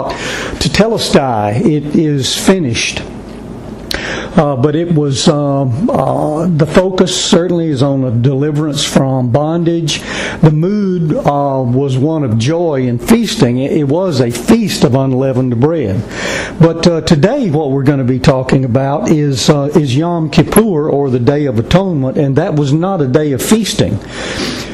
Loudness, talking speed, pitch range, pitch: -12 LUFS, 155 wpm, 135-170 Hz, 150 Hz